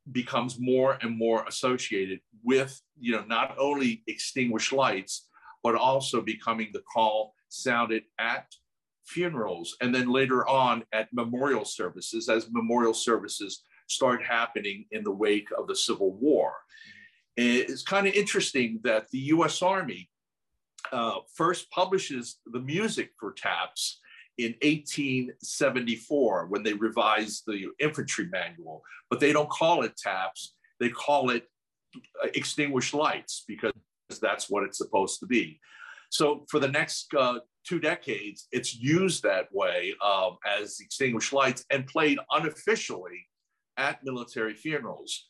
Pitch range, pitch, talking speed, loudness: 115-150 Hz, 125 Hz, 135 wpm, -28 LUFS